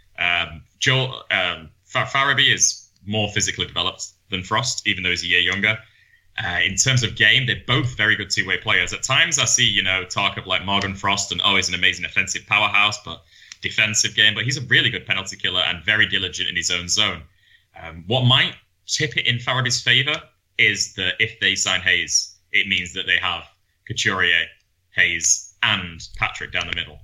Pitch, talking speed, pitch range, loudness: 100 Hz, 195 wpm, 90-110 Hz, -19 LUFS